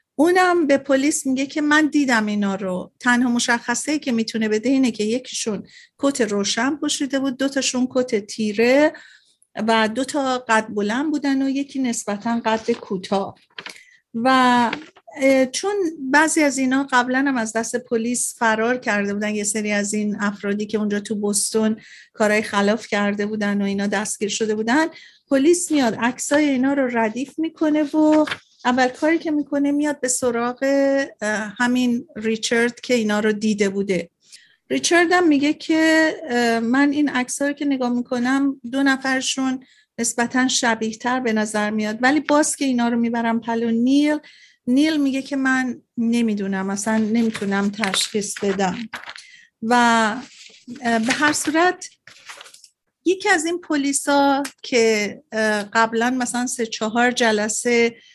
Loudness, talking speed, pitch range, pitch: -20 LUFS, 145 wpm, 220-280 Hz, 245 Hz